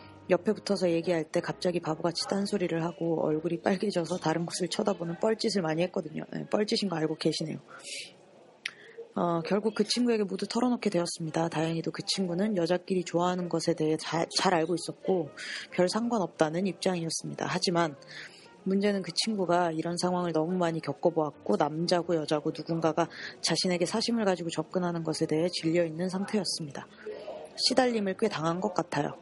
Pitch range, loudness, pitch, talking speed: 165-195 Hz, -30 LUFS, 175 Hz, 390 characters per minute